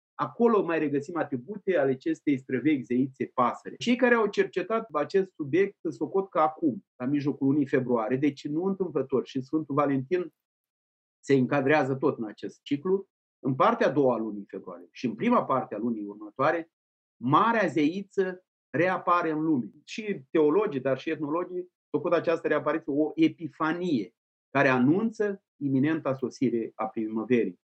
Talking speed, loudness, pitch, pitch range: 150 wpm, -27 LUFS, 155 Hz, 135-180 Hz